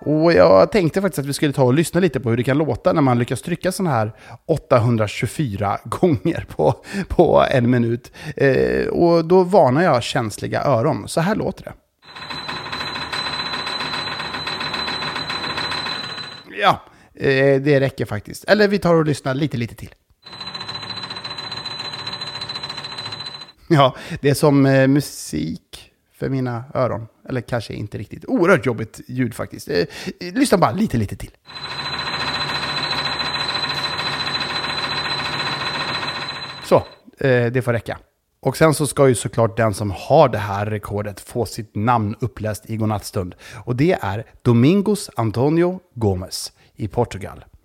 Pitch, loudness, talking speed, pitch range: 130 Hz, -19 LUFS, 130 wpm, 110-150 Hz